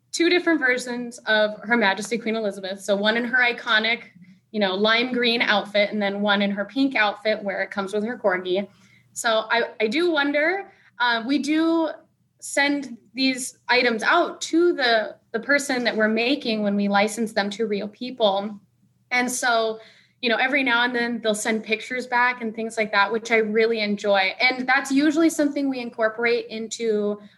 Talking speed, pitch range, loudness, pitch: 185 wpm, 210-255 Hz, -22 LUFS, 230 Hz